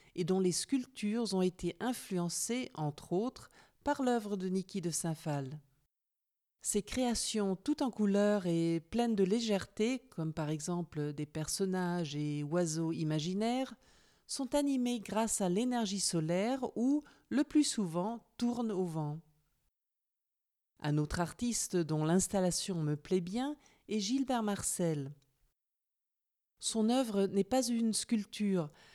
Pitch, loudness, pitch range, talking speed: 195 Hz, -34 LUFS, 165-235 Hz, 130 wpm